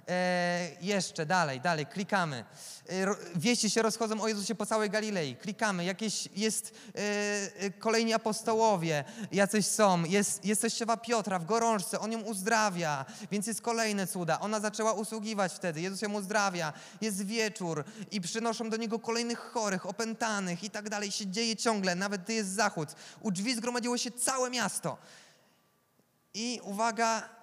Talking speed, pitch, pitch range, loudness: 150 wpm, 210 Hz, 190-225 Hz, -31 LUFS